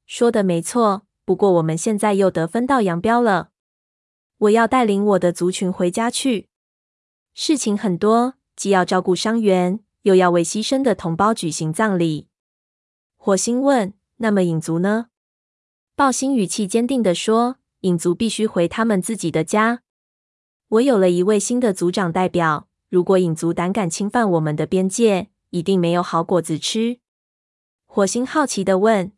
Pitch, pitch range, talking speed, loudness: 195 Hz, 175-225 Hz, 235 characters per minute, -19 LUFS